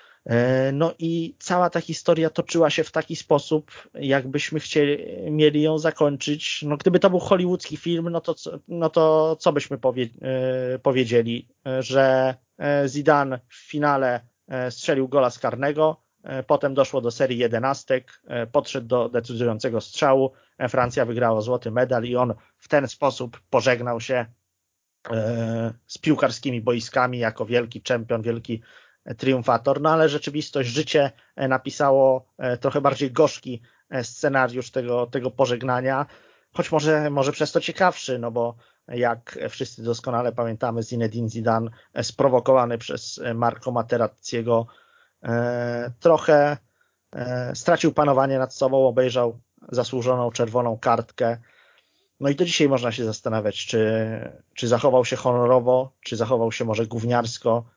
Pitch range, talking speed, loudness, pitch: 120-145 Hz, 125 wpm, -23 LUFS, 130 Hz